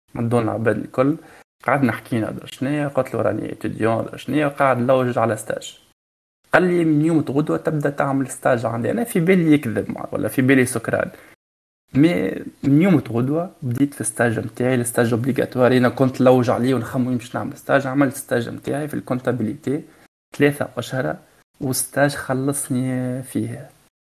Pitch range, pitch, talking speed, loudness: 120-145 Hz, 130 Hz, 150 wpm, -20 LUFS